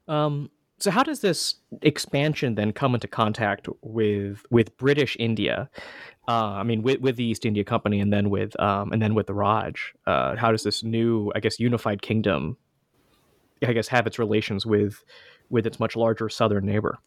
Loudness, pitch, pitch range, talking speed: -24 LUFS, 115 Hz, 105-120 Hz, 185 wpm